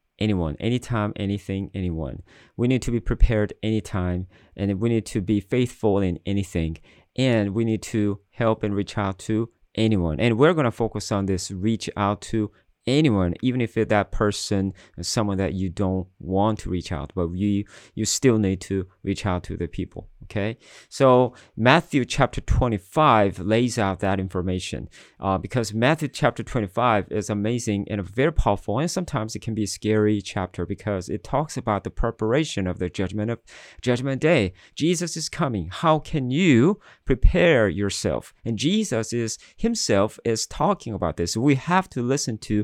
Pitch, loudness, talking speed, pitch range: 105 Hz, -24 LUFS, 175 wpm, 95-120 Hz